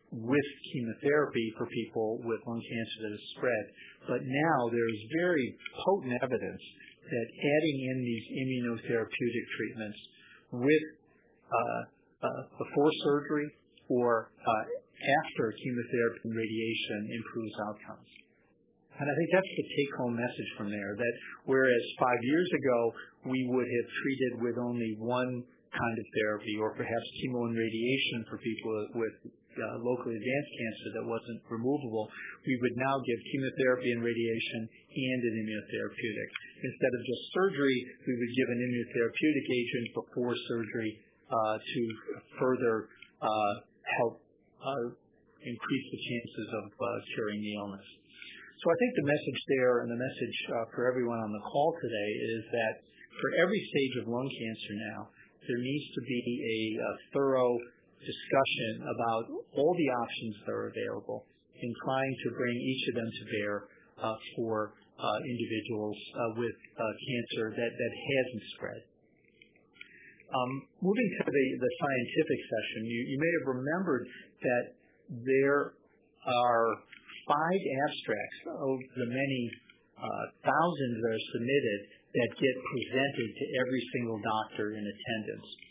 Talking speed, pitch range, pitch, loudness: 145 wpm, 115-135 Hz, 120 Hz, -33 LUFS